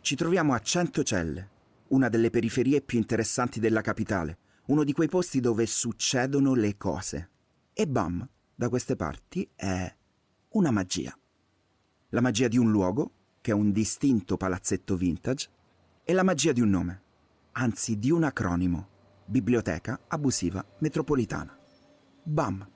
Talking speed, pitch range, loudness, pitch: 135 wpm, 95-130 Hz, -27 LUFS, 115 Hz